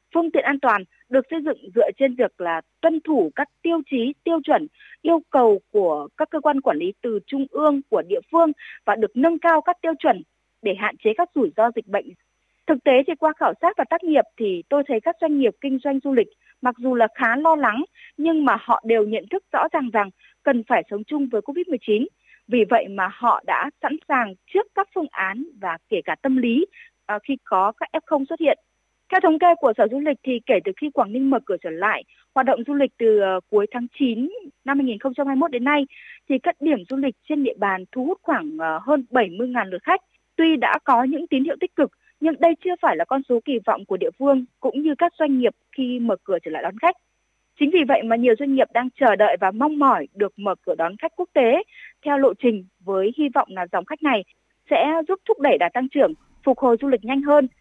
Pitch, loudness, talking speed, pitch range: 275 Hz, -21 LUFS, 235 wpm, 235-325 Hz